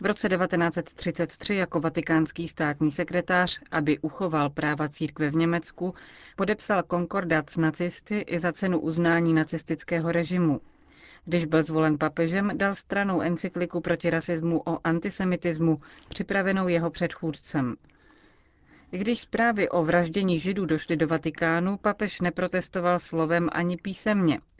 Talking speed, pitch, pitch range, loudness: 125 wpm, 170 Hz, 160-185 Hz, -26 LUFS